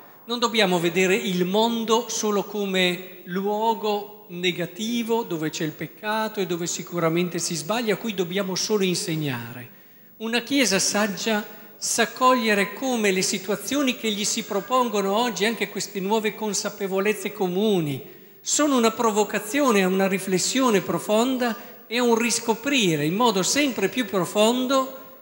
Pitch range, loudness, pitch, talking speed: 190-230 Hz, -23 LUFS, 210 Hz, 135 wpm